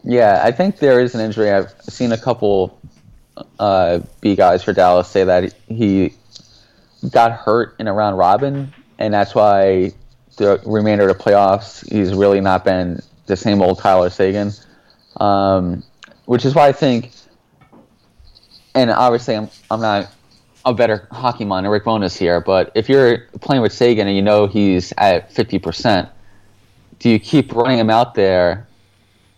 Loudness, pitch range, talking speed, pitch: -15 LUFS, 95-120 Hz, 165 wpm, 105 Hz